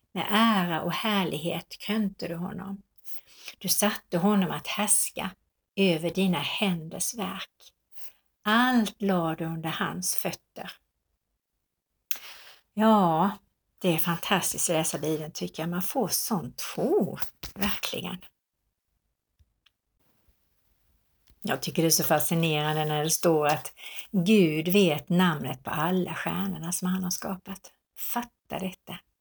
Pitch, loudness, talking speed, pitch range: 180 Hz, -27 LUFS, 120 wpm, 165-200 Hz